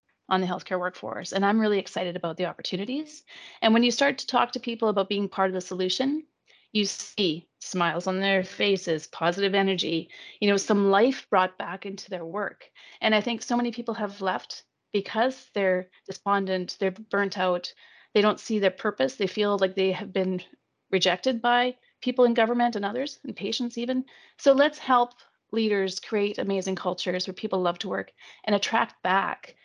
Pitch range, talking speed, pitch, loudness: 190-235 Hz, 185 wpm, 200 Hz, -26 LUFS